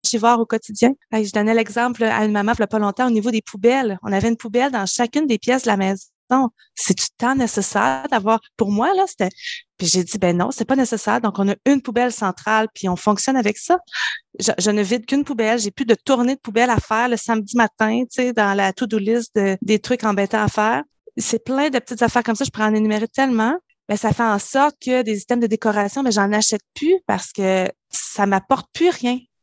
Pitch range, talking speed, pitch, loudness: 210-255 Hz, 245 wpm, 230 Hz, -19 LUFS